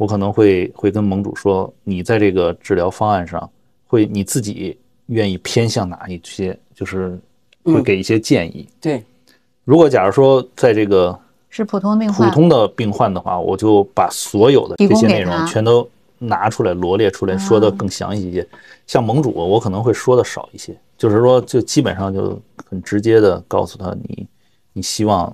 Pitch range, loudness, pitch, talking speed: 95-115 Hz, -16 LUFS, 105 Hz, 270 characters per minute